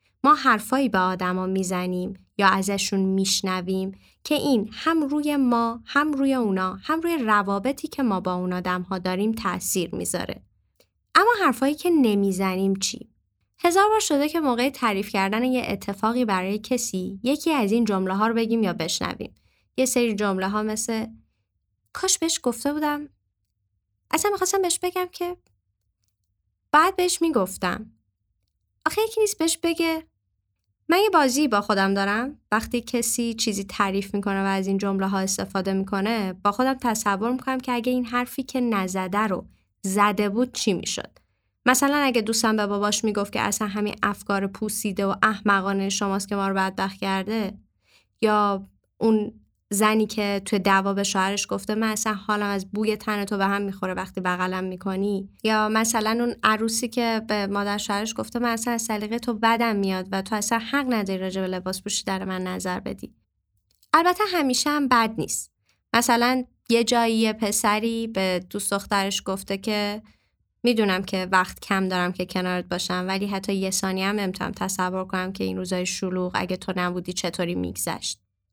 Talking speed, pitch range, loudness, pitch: 165 wpm, 190-240 Hz, -24 LUFS, 205 Hz